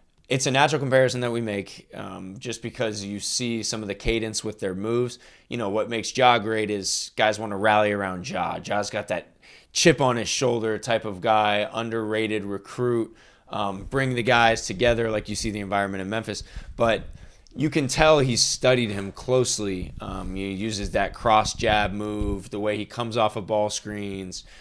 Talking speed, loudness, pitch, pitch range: 195 wpm, -24 LUFS, 110 Hz, 100-120 Hz